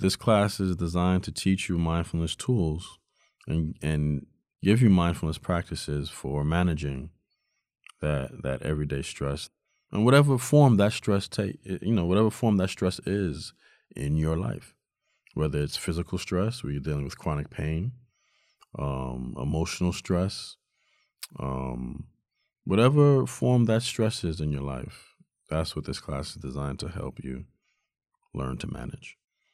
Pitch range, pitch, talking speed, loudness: 75-100 Hz, 85 Hz, 145 wpm, -27 LUFS